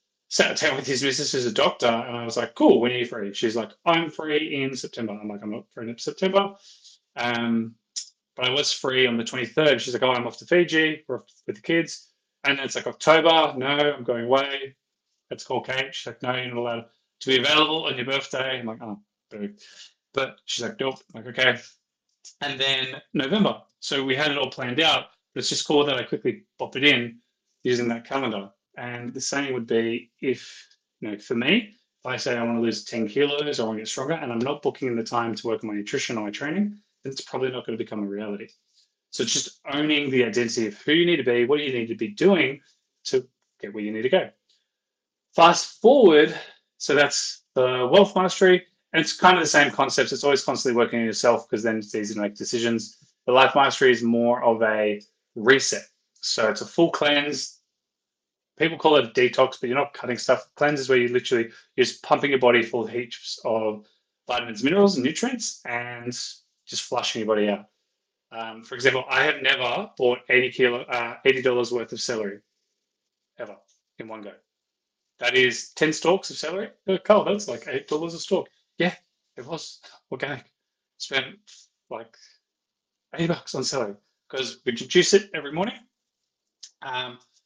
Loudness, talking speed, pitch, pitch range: -23 LUFS, 205 wpm, 130 Hz, 115-150 Hz